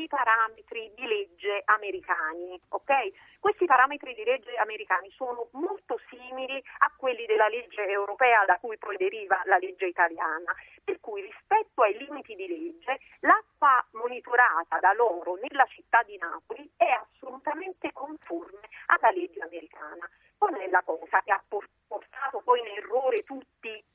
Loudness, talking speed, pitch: -27 LUFS, 145 wpm, 260 Hz